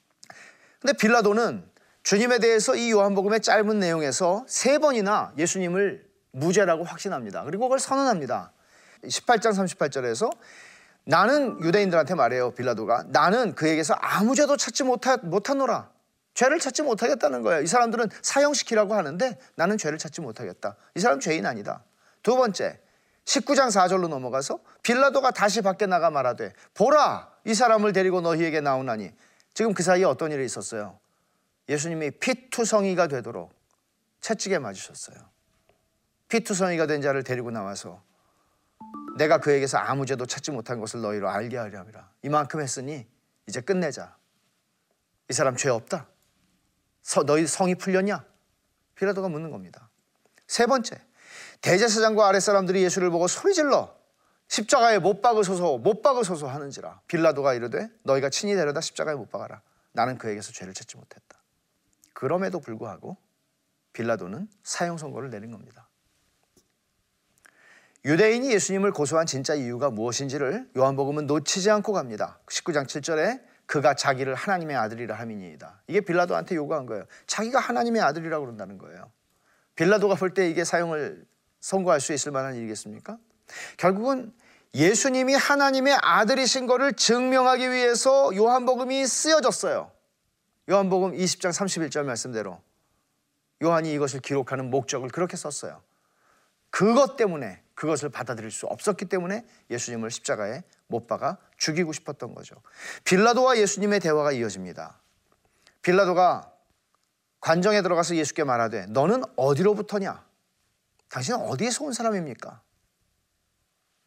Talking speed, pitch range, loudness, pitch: 340 characters per minute, 140-225 Hz, -24 LUFS, 180 Hz